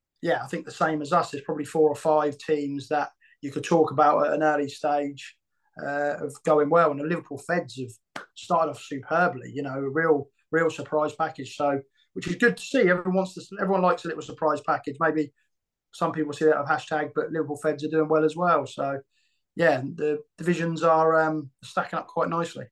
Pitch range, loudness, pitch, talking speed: 145-165 Hz, -25 LUFS, 155 Hz, 215 wpm